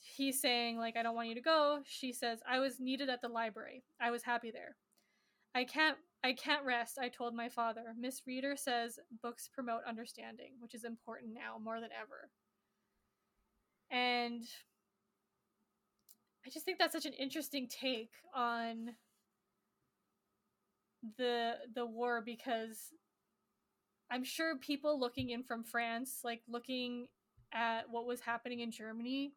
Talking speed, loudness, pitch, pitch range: 145 wpm, -39 LUFS, 240 Hz, 230-260 Hz